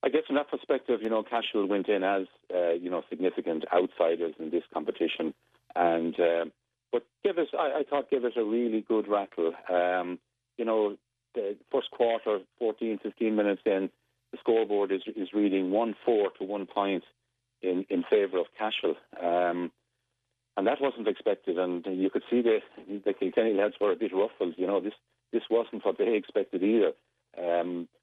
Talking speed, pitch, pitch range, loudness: 180 wpm, 105 Hz, 90-120 Hz, -29 LUFS